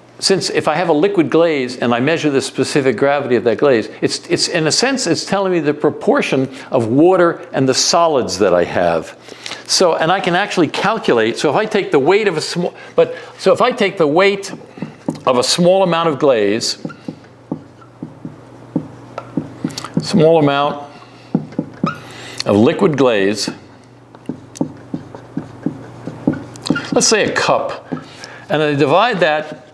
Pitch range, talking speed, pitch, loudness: 135-190 Hz, 150 wpm, 155 Hz, -15 LUFS